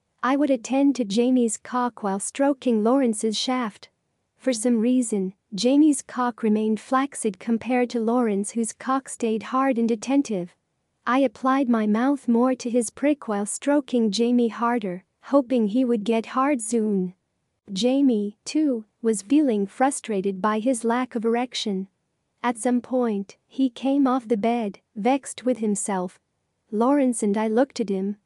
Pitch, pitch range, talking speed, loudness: 235 Hz, 215-260 Hz, 150 wpm, -23 LUFS